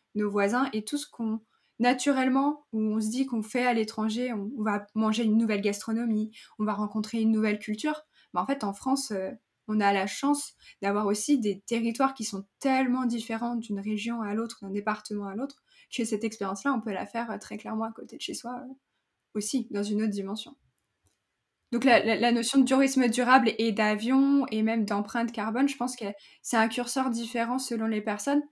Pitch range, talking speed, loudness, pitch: 215-260 Hz, 200 wpm, -28 LUFS, 225 Hz